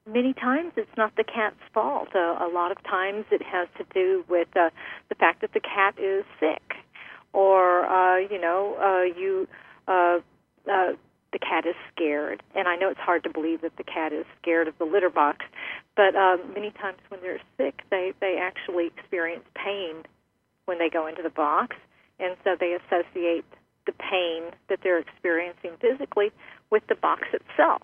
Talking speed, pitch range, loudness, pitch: 185 wpm, 170-200 Hz, -26 LUFS, 185 Hz